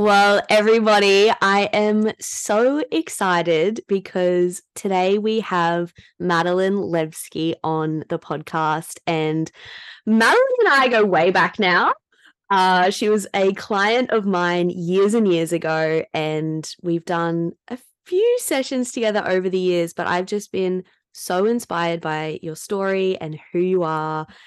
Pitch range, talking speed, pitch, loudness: 170-210 Hz, 140 wpm, 185 Hz, -19 LUFS